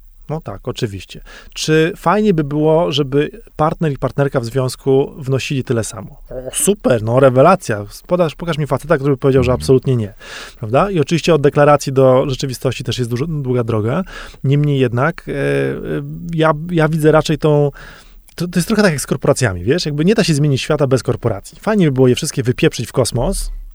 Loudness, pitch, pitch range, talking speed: -16 LUFS, 140 Hz, 125-155 Hz, 185 wpm